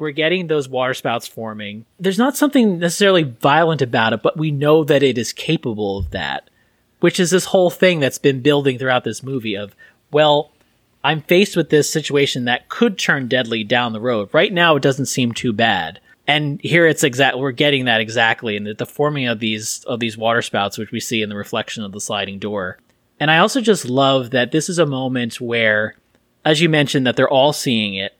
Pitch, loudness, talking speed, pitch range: 135 Hz, -17 LUFS, 210 wpm, 115-155 Hz